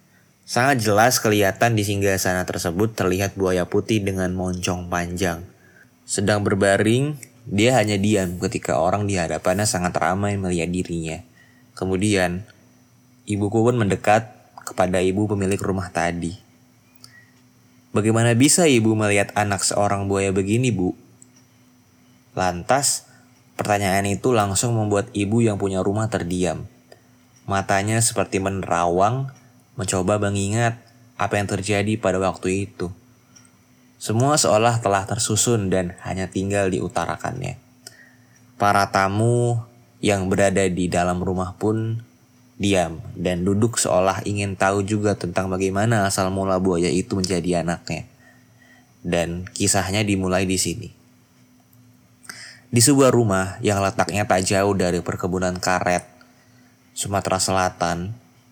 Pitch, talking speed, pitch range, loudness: 100 Hz, 115 wpm, 95-120 Hz, -21 LUFS